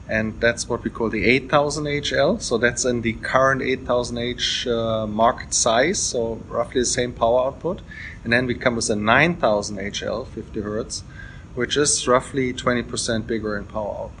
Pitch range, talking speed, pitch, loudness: 115-130 Hz, 175 wpm, 120 Hz, -21 LUFS